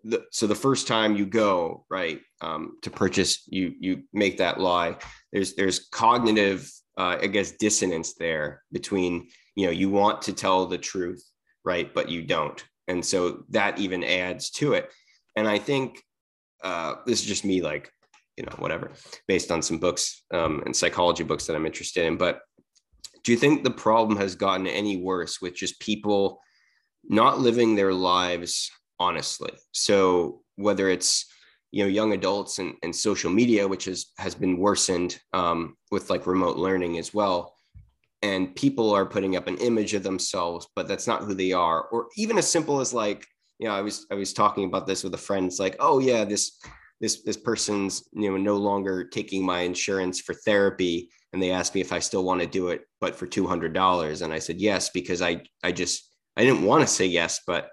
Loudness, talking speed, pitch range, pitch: -25 LUFS, 195 wpm, 90-105 Hz, 95 Hz